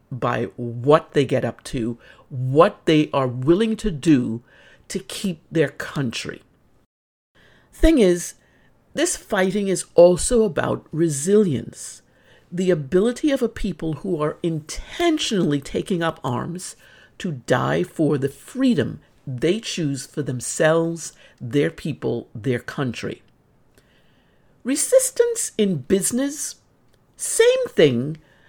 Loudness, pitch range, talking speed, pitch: -21 LUFS, 145-215 Hz, 110 wpm, 170 Hz